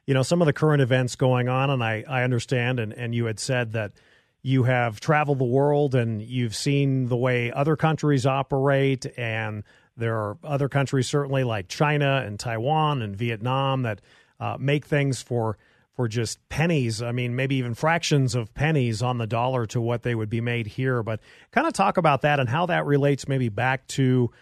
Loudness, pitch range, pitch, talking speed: -24 LUFS, 120-140 Hz, 130 Hz, 200 wpm